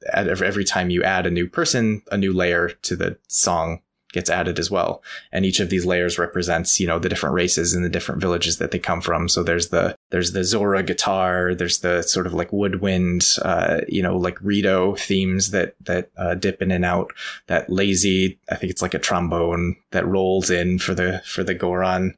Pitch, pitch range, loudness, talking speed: 90 Hz, 90-95 Hz, -20 LUFS, 210 wpm